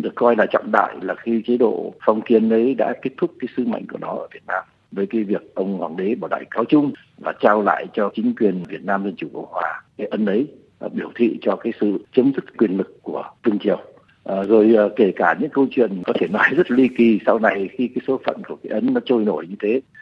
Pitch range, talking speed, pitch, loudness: 100-130 Hz, 265 wpm, 115 Hz, -20 LUFS